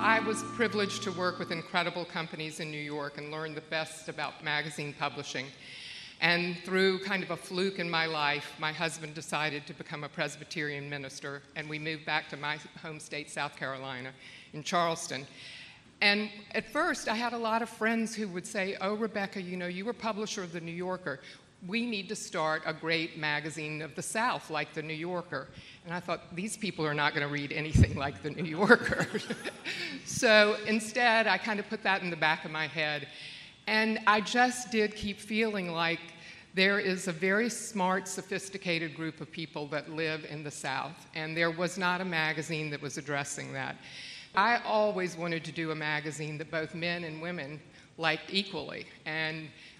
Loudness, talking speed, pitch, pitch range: -31 LUFS, 190 wpm, 165 Hz, 150-195 Hz